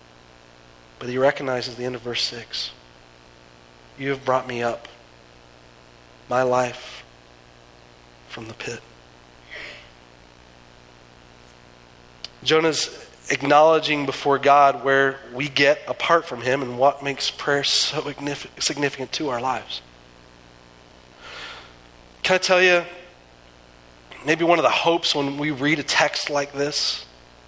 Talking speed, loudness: 115 wpm, -21 LUFS